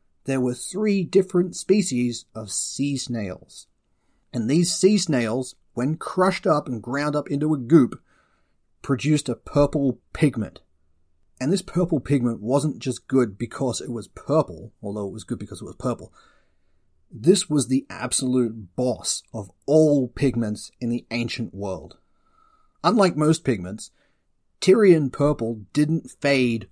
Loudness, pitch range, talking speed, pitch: -23 LUFS, 110-155 Hz, 140 wpm, 130 Hz